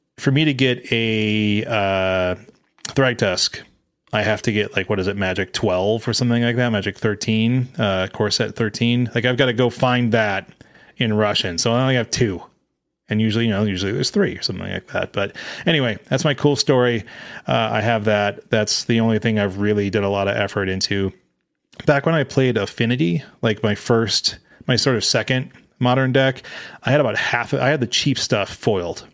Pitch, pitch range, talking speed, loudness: 115 Hz, 105-125 Hz, 200 wpm, -19 LUFS